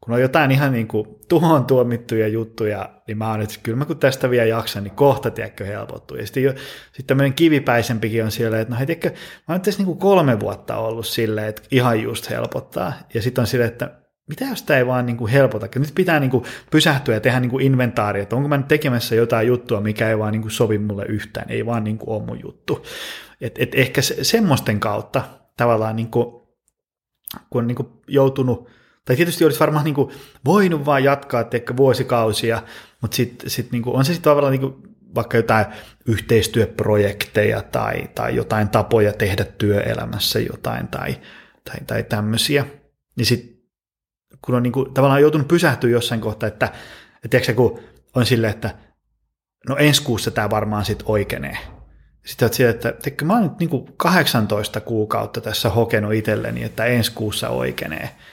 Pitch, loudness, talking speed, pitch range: 120 Hz, -19 LUFS, 185 wpm, 110-135 Hz